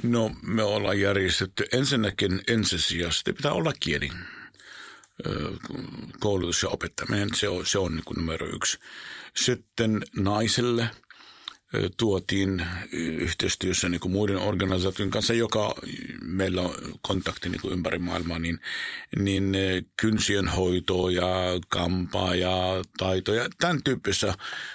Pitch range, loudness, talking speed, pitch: 90-105 Hz, -27 LUFS, 105 wpm, 95 Hz